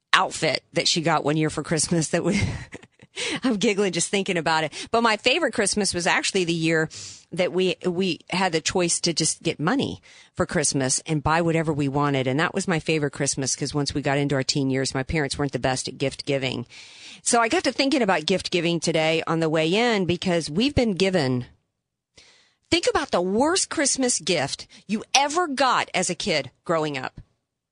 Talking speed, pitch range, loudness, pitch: 205 wpm, 150-205 Hz, -23 LUFS, 170 Hz